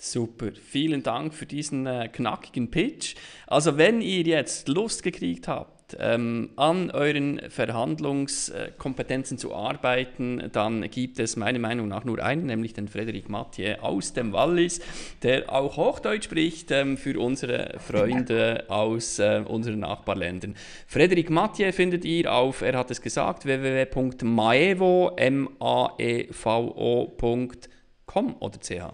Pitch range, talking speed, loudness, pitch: 115-145 Hz, 125 wpm, -26 LUFS, 125 Hz